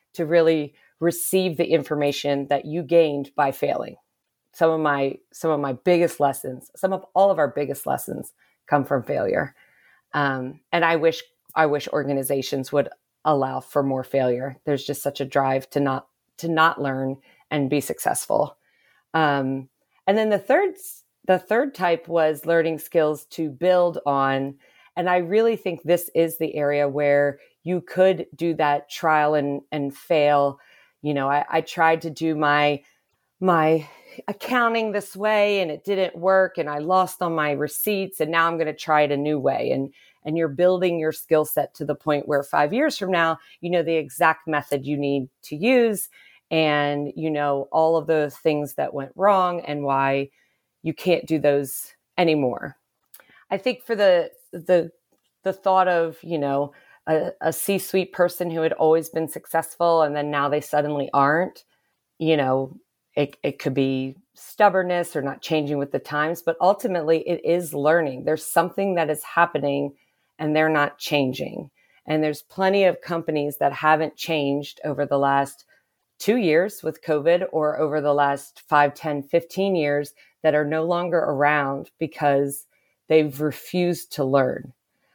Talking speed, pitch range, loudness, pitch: 170 wpm, 145-175 Hz, -22 LUFS, 155 Hz